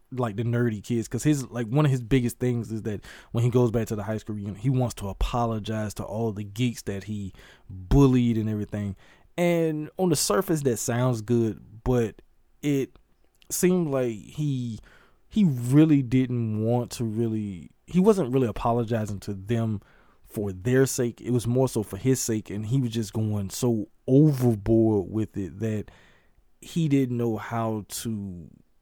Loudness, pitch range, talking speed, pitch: -26 LUFS, 110-130 Hz, 180 wpm, 120 Hz